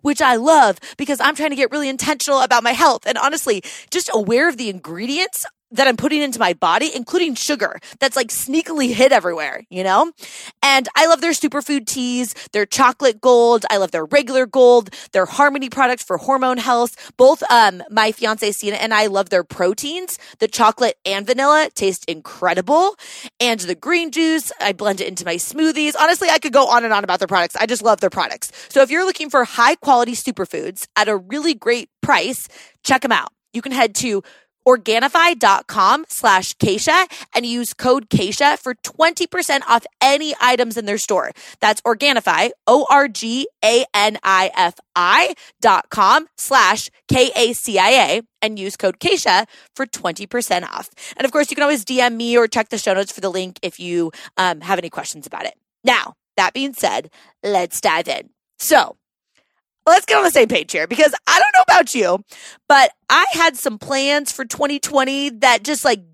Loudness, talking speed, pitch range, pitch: -16 LUFS, 180 wpm, 215-290 Hz, 255 Hz